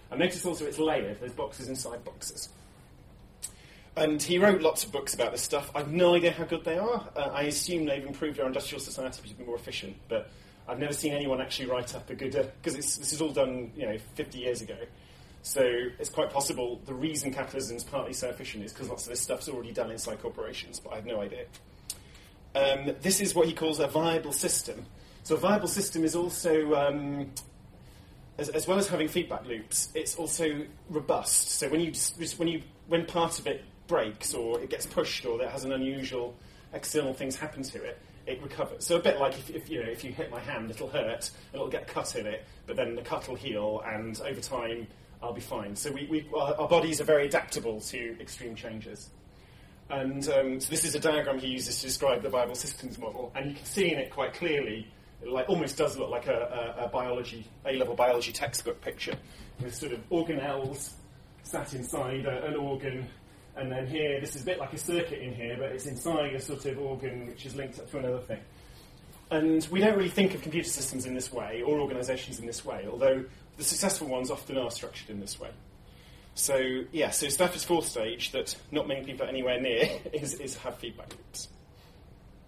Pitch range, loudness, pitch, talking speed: 125-160 Hz, -31 LUFS, 140 Hz, 215 wpm